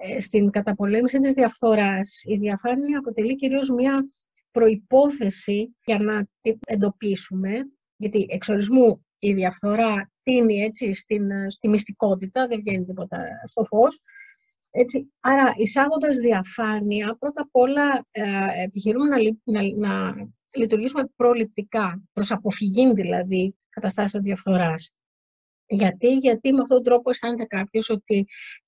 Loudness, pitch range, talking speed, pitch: -22 LUFS, 200-250 Hz, 125 wpm, 220 Hz